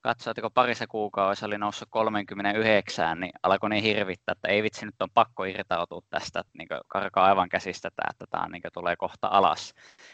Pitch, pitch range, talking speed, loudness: 105 Hz, 100-115 Hz, 165 wpm, -27 LUFS